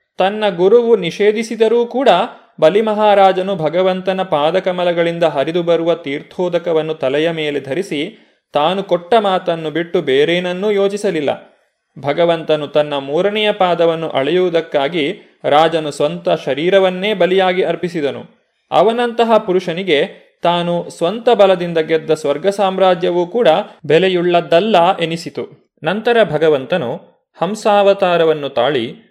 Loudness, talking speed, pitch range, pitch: -15 LUFS, 90 wpm, 160-200 Hz, 175 Hz